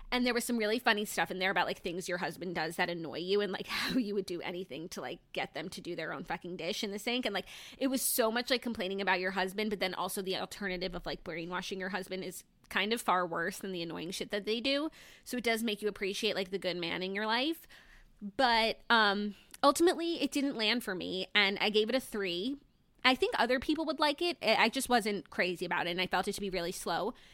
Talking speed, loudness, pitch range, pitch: 260 wpm, -33 LUFS, 185-240 Hz, 205 Hz